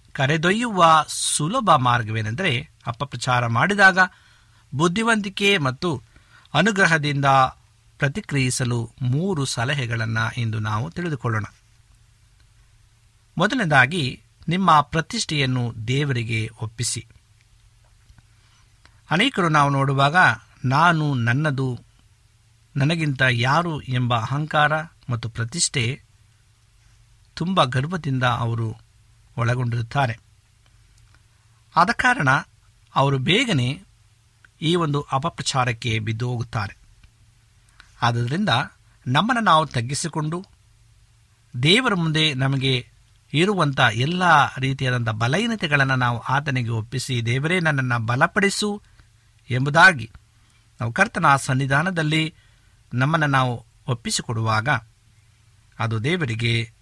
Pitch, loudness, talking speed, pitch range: 125 Hz, -21 LUFS, 75 wpm, 110-150 Hz